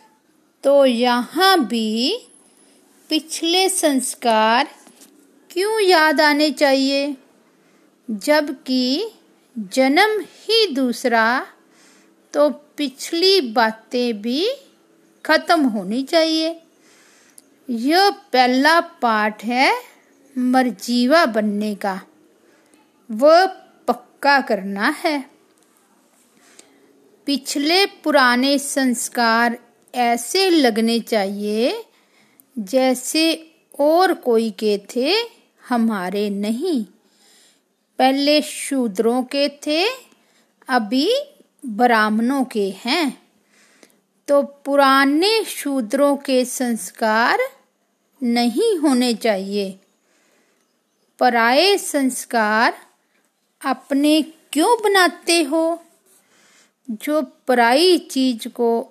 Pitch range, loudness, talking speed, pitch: 235-320 Hz, -18 LUFS, 70 wpm, 275 Hz